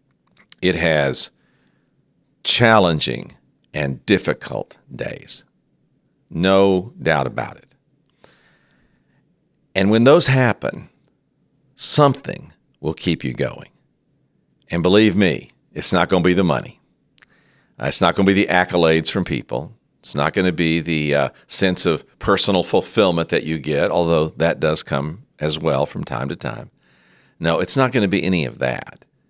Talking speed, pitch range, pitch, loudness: 145 wpm, 70-100 Hz, 85 Hz, -18 LUFS